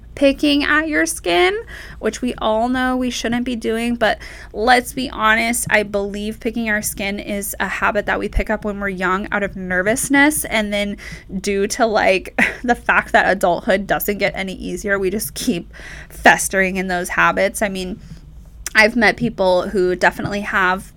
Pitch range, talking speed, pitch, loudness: 195-235 Hz, 175 wpm, 210 Hz, -17 LUFS